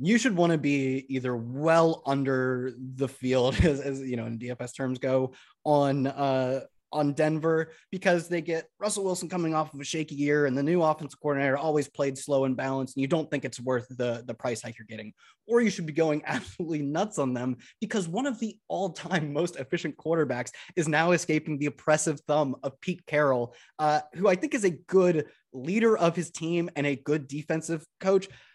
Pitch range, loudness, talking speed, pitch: 135-170 Hz, -28 LUFS, 205 wpm, 150 Hz